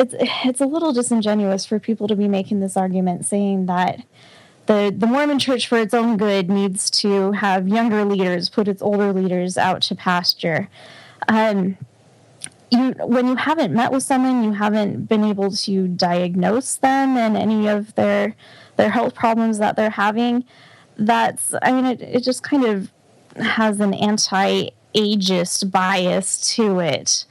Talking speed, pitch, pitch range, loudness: 160 wpm, 210 Hz, 190-230 Hz, -19 LUFS